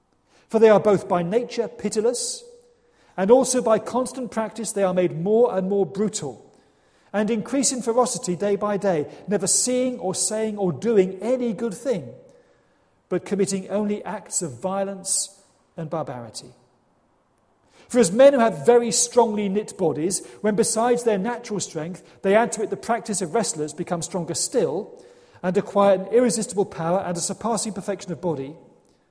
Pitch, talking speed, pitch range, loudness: 210 Hz, 165 wpm, 185-235 Hz, -22 LUFS